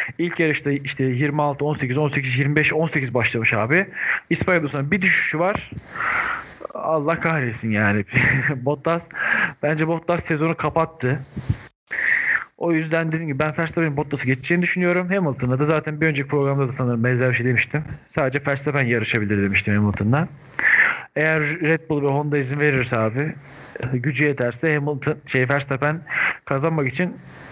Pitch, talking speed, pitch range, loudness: 145 Hz, 140 wpm, 130-160 Hz, -21 LUFS